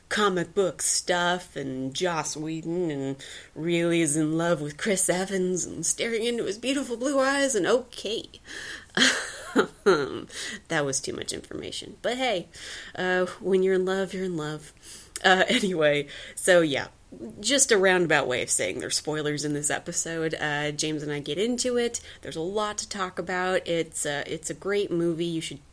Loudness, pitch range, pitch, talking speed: -26 LUFS, 150-190 Hz, 170 Hz, 175 wpm